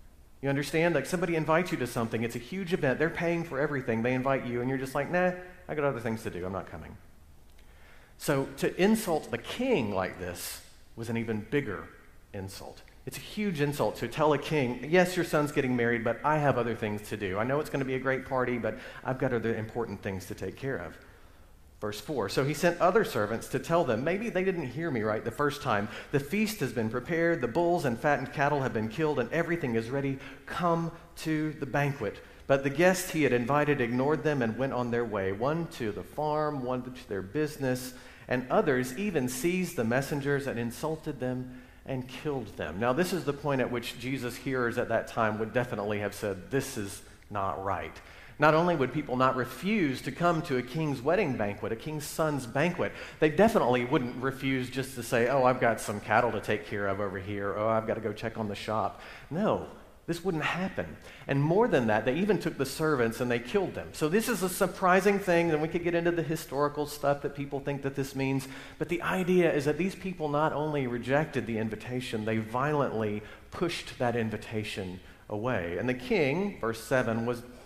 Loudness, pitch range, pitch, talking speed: -30 LUFS, 115-155 Hz, 130 Hz, 220 wpm